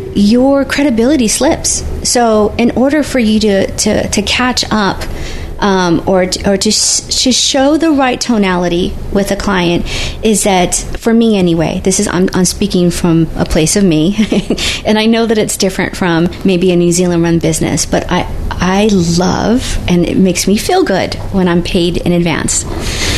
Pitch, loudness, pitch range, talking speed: 195 Hz, -11 LUFS, 175-230 Hz, 185 wpm